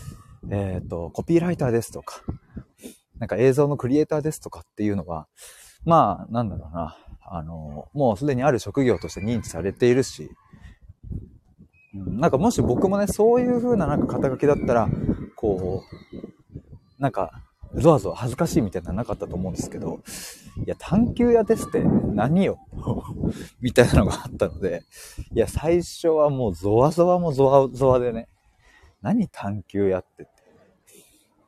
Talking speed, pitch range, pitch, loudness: 325 characters per minute, 100-165 Hz, 125 Hz, -23 LUFS